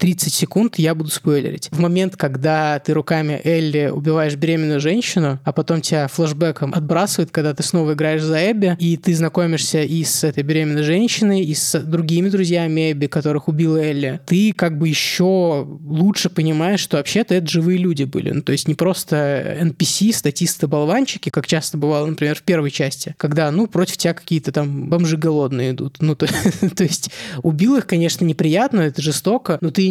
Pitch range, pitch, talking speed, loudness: 150-175 Hz, 165 Hz, 175 wpm, -18 LUFS